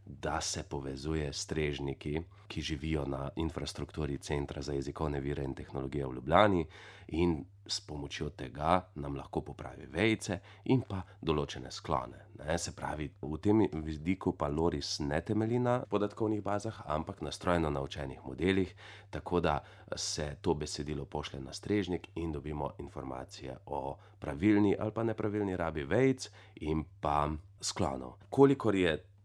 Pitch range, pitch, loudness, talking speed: 75-100 Hz, 80 Hz, -34 LUFS, 140 wpm